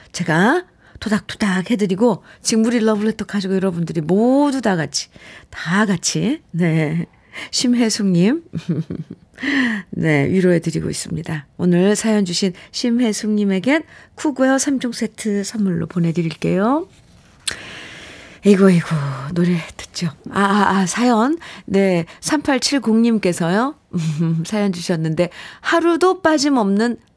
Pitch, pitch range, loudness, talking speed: 200 Hz, 175-240 Hz, -18 LUFS, 245 characters per minute